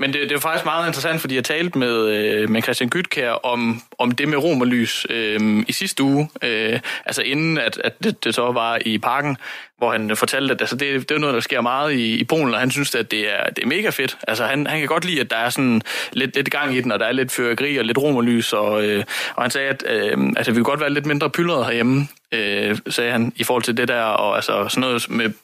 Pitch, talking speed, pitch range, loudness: 125 Hz, 260 wpm, 115-145 Hz, -19 LUFS